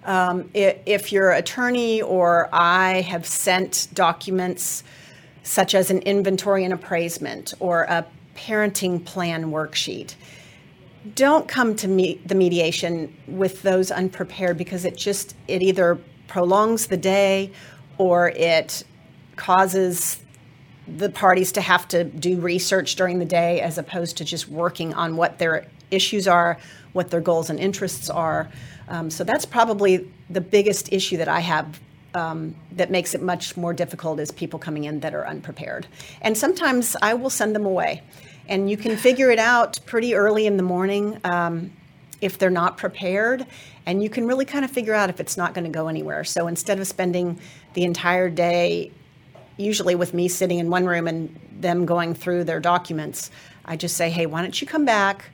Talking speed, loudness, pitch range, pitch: 170 wpm, -21 LUFS, 170-195 Hz, 180 Hz